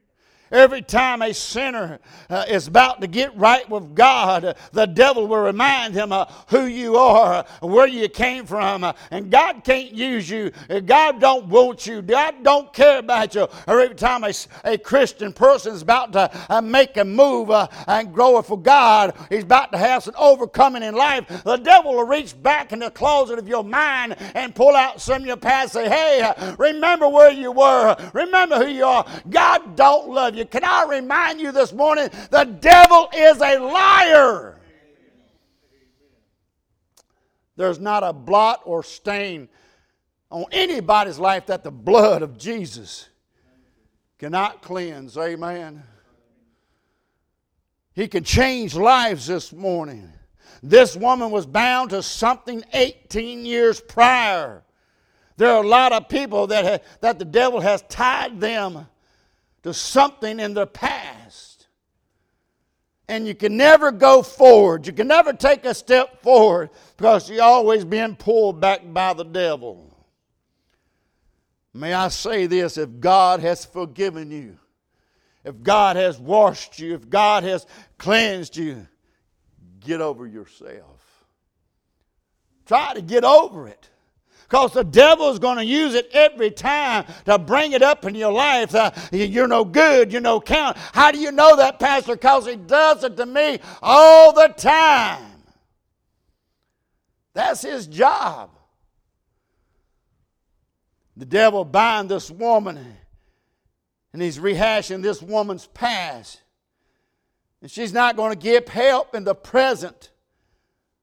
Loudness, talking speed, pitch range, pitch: -16 LUFS, 150 wpm, 185-260 Hz, 225 Hz